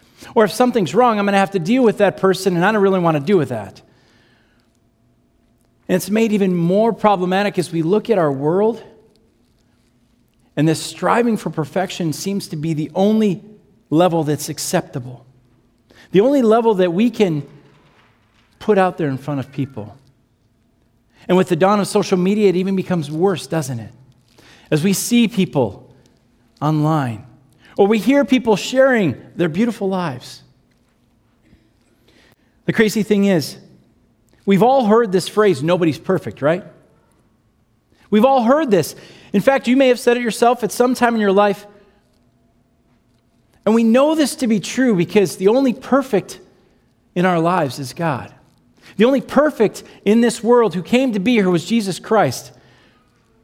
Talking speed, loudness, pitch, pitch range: 165 wpm, -17 LUFS, 180 Hz, 125-210 Hz